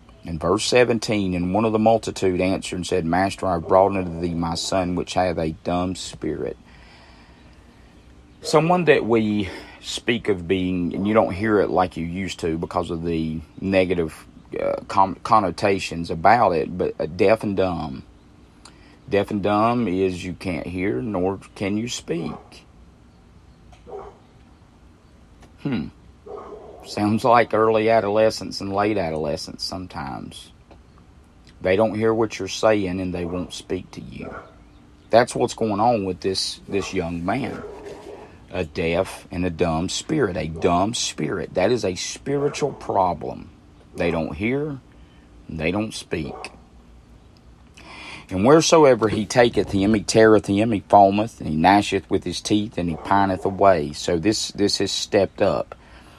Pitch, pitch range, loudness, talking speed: 95 Hz, 80-105 Hz, -21 LUFS, 150 wpm